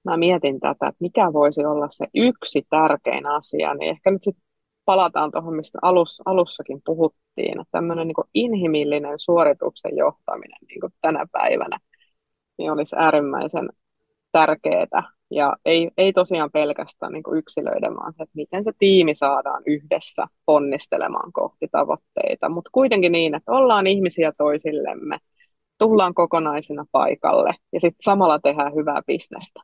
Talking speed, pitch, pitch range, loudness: 140 wpm, 160 Hz, 150-185 Hz, -20 LUFS